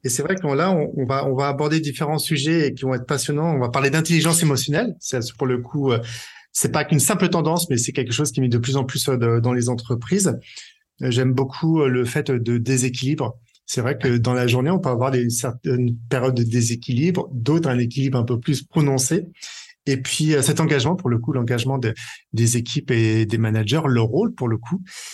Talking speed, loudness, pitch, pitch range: 205 wpm, -21 LUFS, 135 Hz, 125-155 Hz